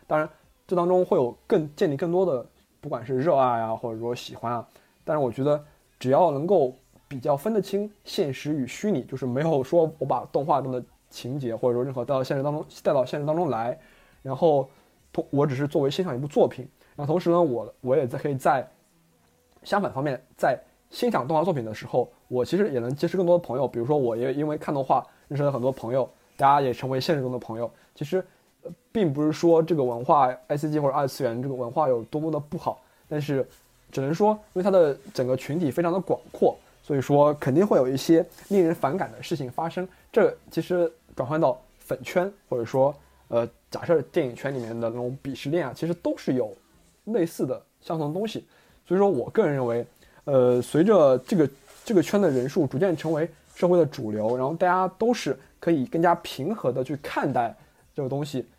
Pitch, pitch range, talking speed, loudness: 150 Hz, 130-175 Hz, 315 characters per minute, -25 LUFS